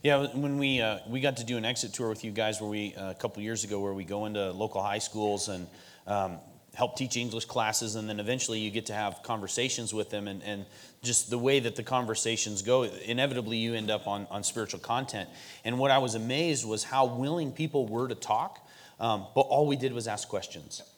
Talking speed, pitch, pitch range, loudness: 230 wpm, 115 Hz, 105-125 Hz, -31 LUFS